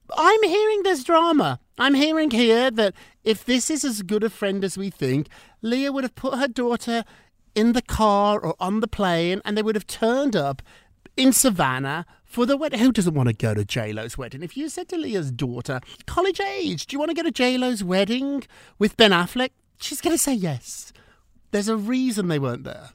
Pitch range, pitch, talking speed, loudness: 175-275 Hz, 225 Hz, 215 wpm, -22 LUFS